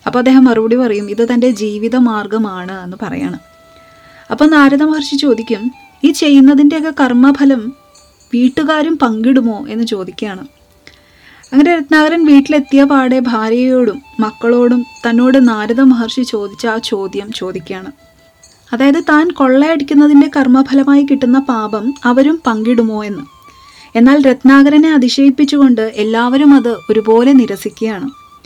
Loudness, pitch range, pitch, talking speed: -10 LUFS, 225-285 Hz, 255 Hz, 105 wpm